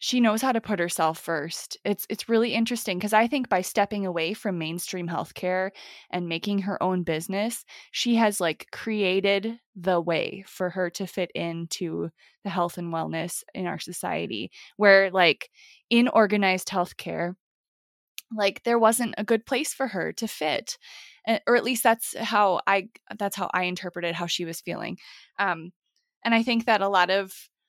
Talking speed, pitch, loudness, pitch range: 175 wpm, 200 Hz, -25 LUFS, 180-230 Hz